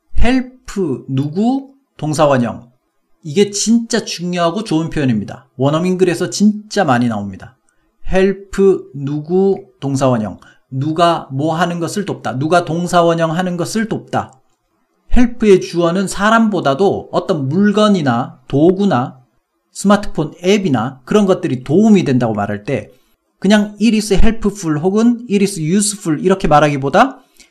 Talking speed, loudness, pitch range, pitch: 305 characters per minute, -15 LUFS, 140-200 Hz, 180 Hz